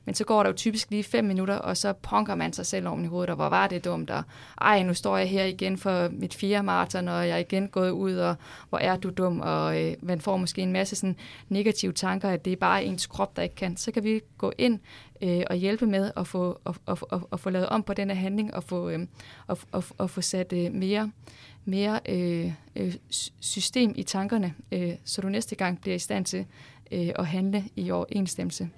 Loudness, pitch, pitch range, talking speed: -28 LUFS, 185 Hz, 175-200 Hz, 225 wpm